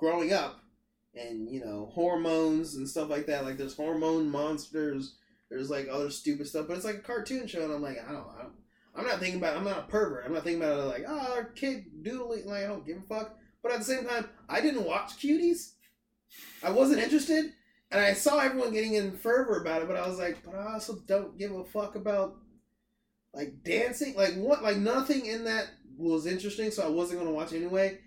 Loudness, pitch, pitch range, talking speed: -31 LUFS, 195 Hz, 160-230 Hz, 225 wpm